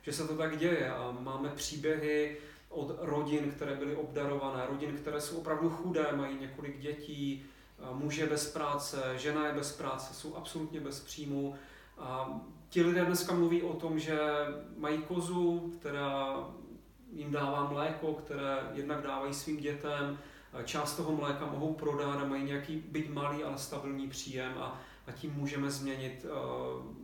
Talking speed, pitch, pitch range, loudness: 150 wpm, 145 Hz, 140-155 Hz, -36 LUFS